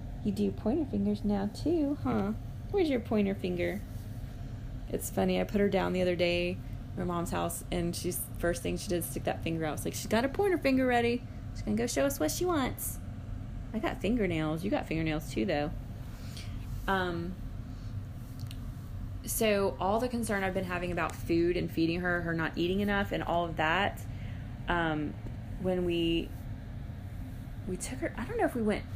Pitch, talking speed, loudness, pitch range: 120 Hz, 190 wpm, -32 LUFS, 105-175 Hz